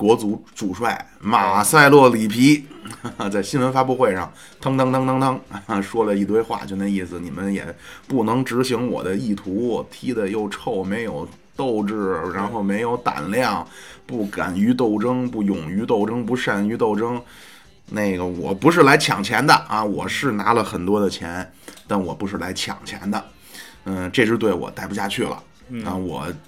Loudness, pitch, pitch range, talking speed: -20 LUFS, 105 Hz, 95-125 Hz, 245 characters per minute